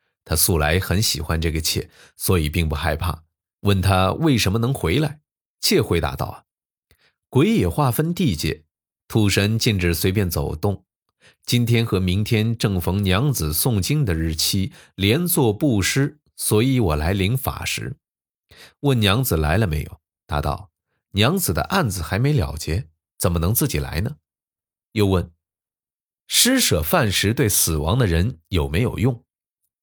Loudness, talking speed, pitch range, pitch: -20 LUFS, 215 characters per minute, 85-120 Hz, 95 Hz